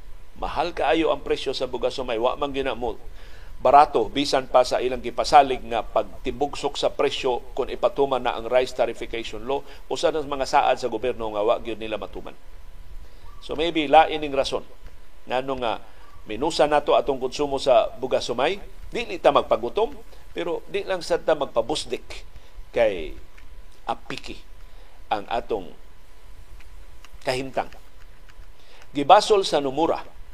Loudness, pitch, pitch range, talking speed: -23 LUFS, 130 Hz, 100-150 Hz, 140 wpm